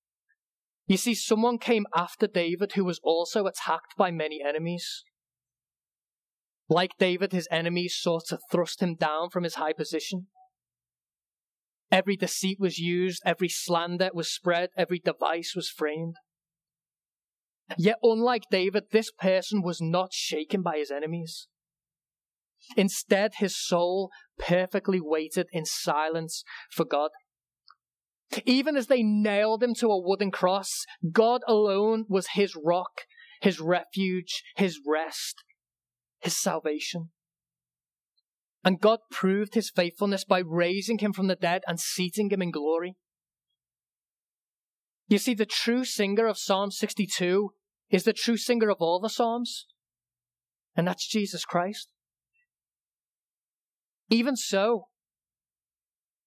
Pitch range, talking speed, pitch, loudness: 170-210 Hz, 125 wpm, 185 Hz, -27 LUFS